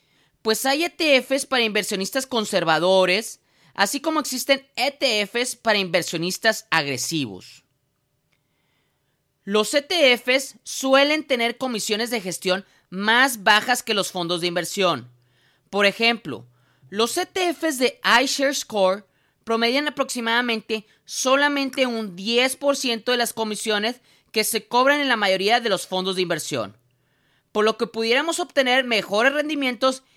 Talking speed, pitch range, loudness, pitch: 120 wpm, 185-260 Hz, -21 LUFS, 225 Hz